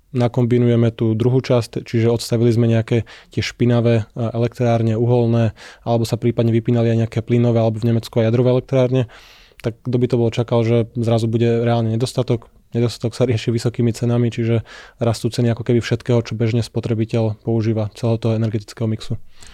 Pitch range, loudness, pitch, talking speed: 115-120 Hz, -19 LUFS, 115 Hz, 170 wpm